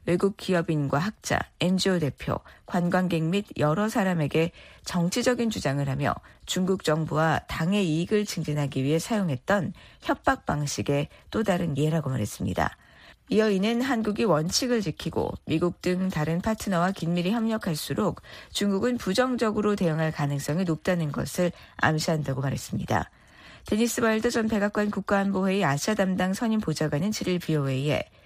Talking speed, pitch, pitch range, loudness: 340 characters per minute, 180 Hz, 155-205 Hz, -26 LUFS